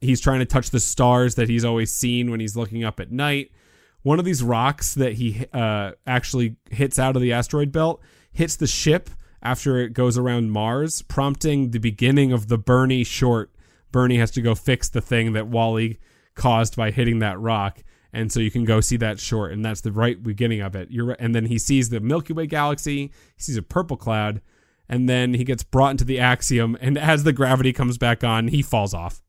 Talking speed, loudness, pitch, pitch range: 220 wpm, -21 LUFS, 120 Hz, 115-135 Hz